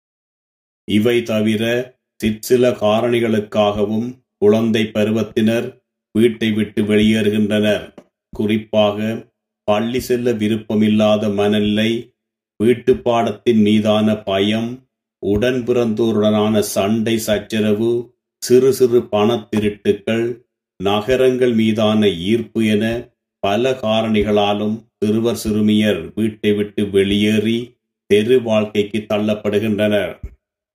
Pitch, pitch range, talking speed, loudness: 110 Hz, 105-120 Hz, 70 wpm, -17 LUFS